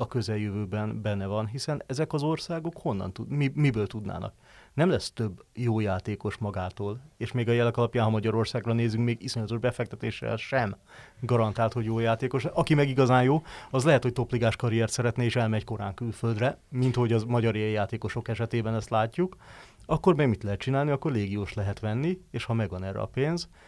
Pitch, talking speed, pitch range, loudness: 115 Hz, 180 wpm, 110-130 Hz, -28 LUFS